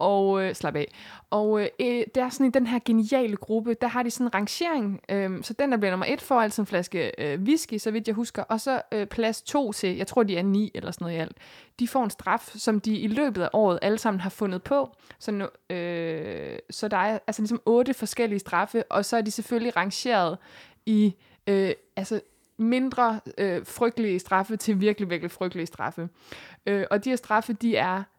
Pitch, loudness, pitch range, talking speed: 215 Hz, -26 LUFS, 195-235 Hz, 220 wpm